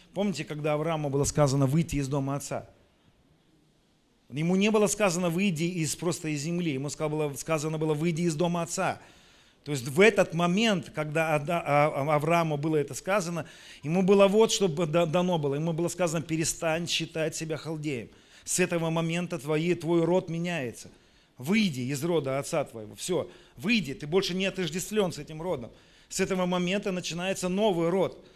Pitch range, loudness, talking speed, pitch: 150-180 Hz, -28 LUFS, 165 wpm, 165 Hz